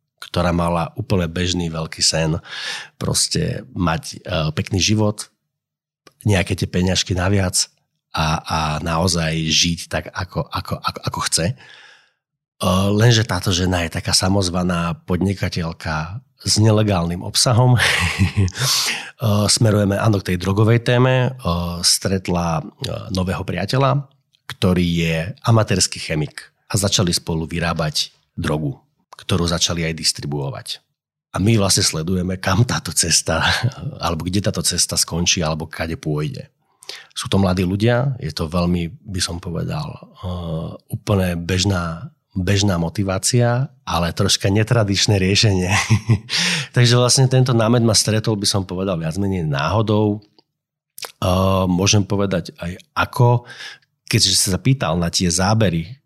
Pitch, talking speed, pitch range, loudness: 95 Hz, 125 wpm, 85-115 Hz, -18 LUFS